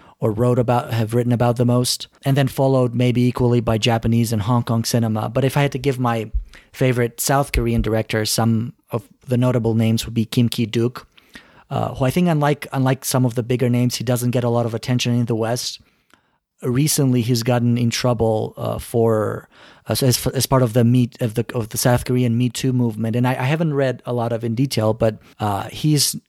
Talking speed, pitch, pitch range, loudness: 220 wpm, 120 Hz, 115-130 Hz, -19 LUFS